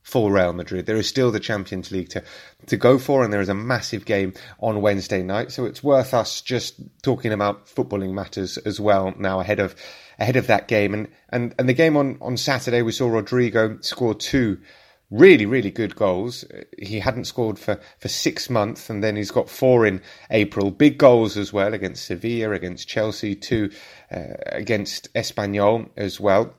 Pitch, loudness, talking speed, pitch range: 105 Hz, -21 LUFS, 190 wpm, 100-125 Hz